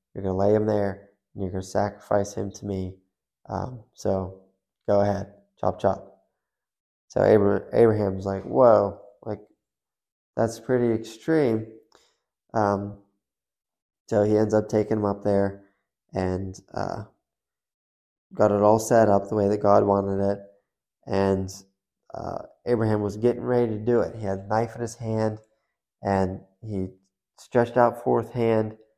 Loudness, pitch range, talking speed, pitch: -24 LUFS, 95-110 Hz, 145 wpm, 100 Hz